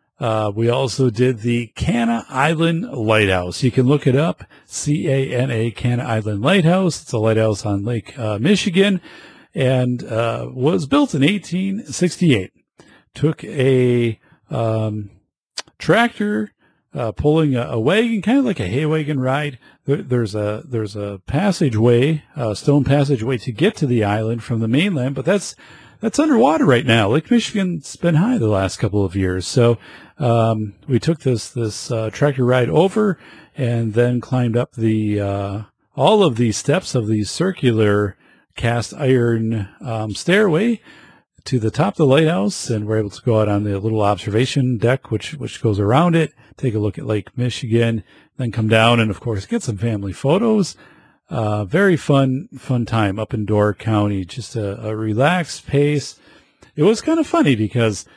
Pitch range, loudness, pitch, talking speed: 110-155 Hz, -18 LUFS, 125 Hz, 170 wpm